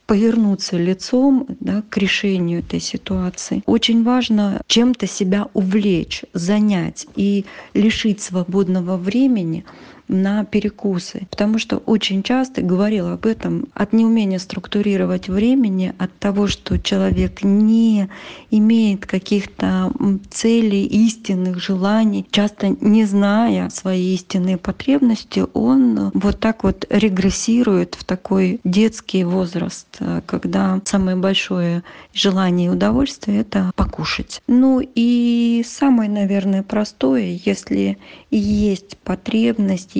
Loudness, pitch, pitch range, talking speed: -18 LUFS, 205 Hz, 185-225 Hz, 105 wpm